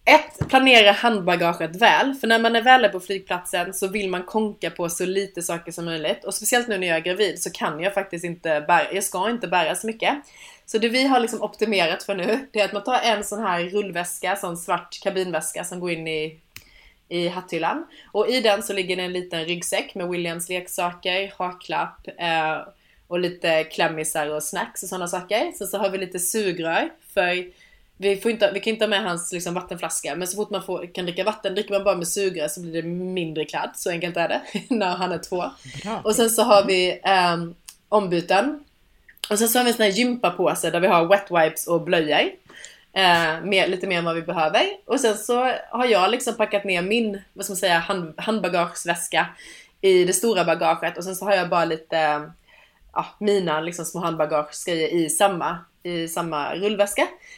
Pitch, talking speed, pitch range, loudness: 185 Hz, 205 wpm, 170-210 Hz, -22 LUFS